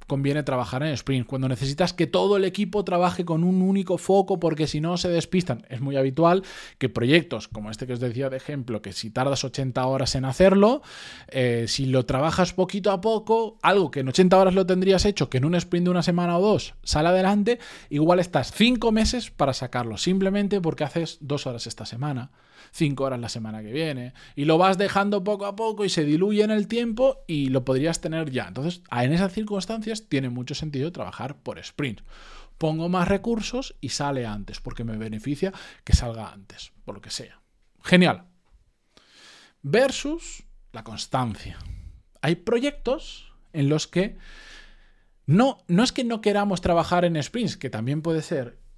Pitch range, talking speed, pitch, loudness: 130-195 Hz, 185 wpm, 160 Hz, -24 LUFS